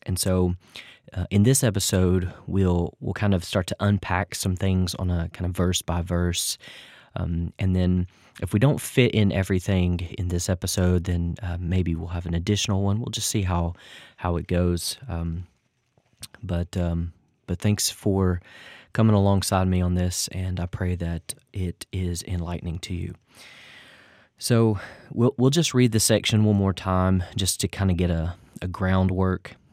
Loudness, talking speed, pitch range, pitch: -24 LUFS, 175 wpm, 90-100 Hz, 95 Hz